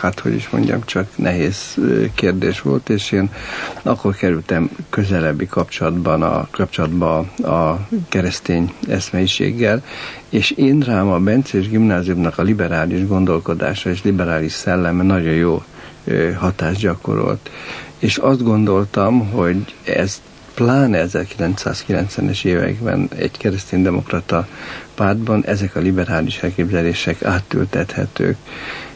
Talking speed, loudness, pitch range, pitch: 105 wpm, -18 LUFS, 85-105 Hz, 95 Hz